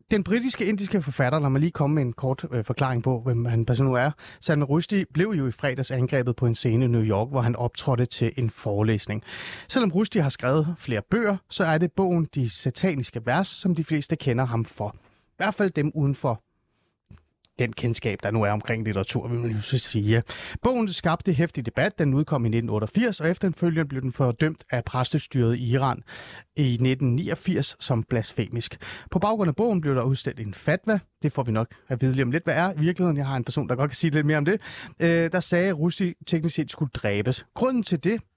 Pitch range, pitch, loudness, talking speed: 120-170 Hz, 140 Hz, -25 LUFS, 220 wpm